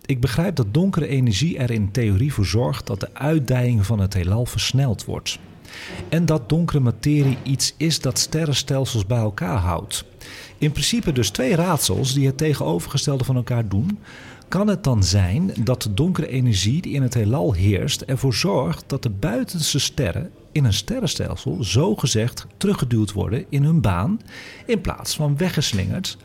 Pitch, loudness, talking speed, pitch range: 130 Hz, -21 LUFS, 165 wpm, 110-150 Hz